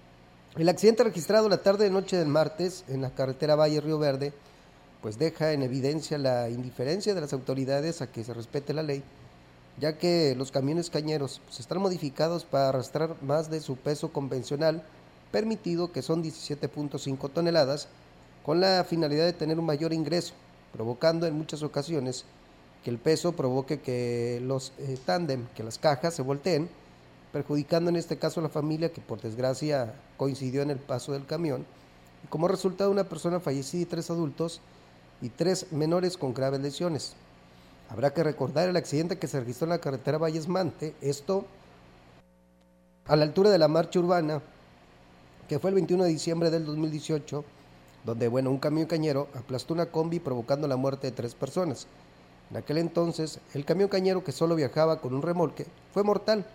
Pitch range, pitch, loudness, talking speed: 130-165 Hz, 150 Hz, -29 LUFS, 170 wpm